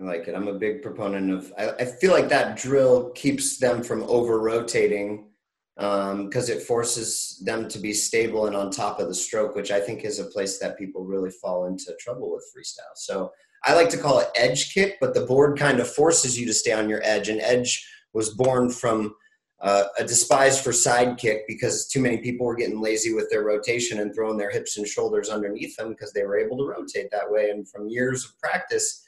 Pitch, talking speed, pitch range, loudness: 115 Hz, 225 wpm, 105-135 Hz, -23 LUFS